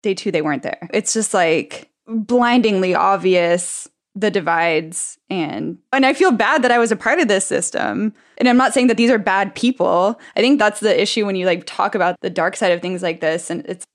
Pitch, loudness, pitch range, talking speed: 205 Hz, -17 LUFS, 180-240 Hz, 230 wpm